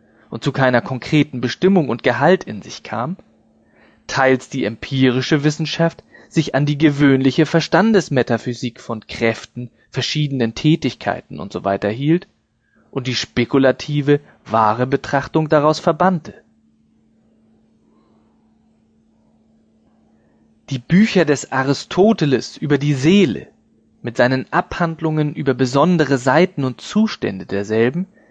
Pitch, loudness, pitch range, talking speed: 140 Hz, -17 LUFS, 120-165 Hz, 105 wpm